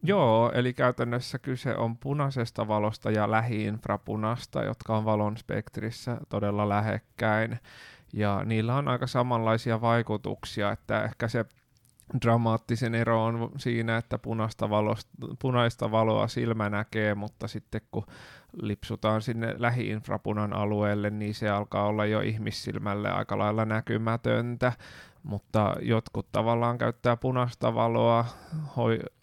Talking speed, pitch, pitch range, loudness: 115 wpm, 115 Hz, 105-120 Hz, -29 LUFS